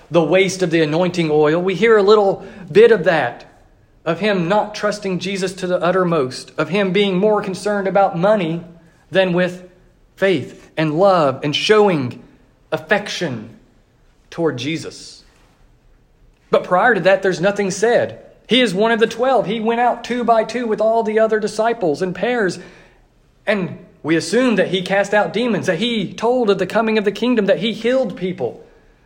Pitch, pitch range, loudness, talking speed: 195 Hz, 170-215 Hz, -17 LUFS, 175 wpm